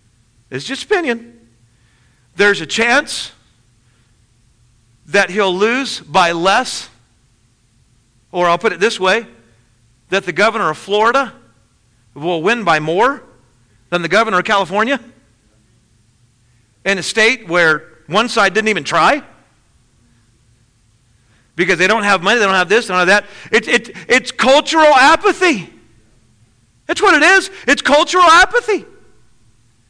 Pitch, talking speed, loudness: 155 Hz, 125 wpm, -13 LUFS